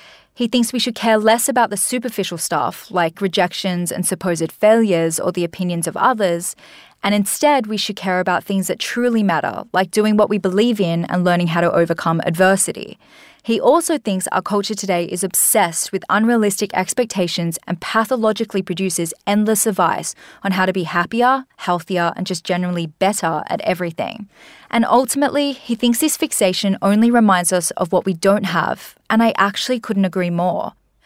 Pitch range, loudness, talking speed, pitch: 180-225 Hz, -18 LUFS, 175 wpm, 195 Hz